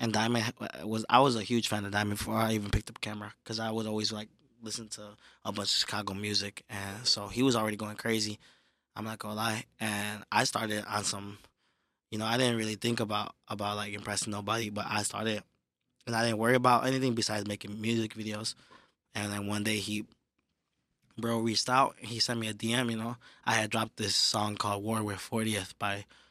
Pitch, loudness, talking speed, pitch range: 110 Hz, -31 LUFS, 215 wpm, 105-115 Hz